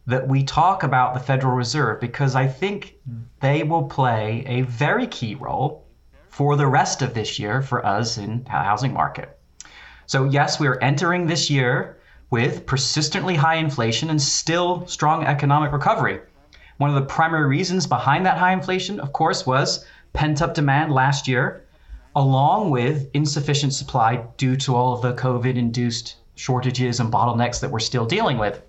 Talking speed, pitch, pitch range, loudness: 170 wpm, 135 Hz, 125-150 Hz, -21 LUFS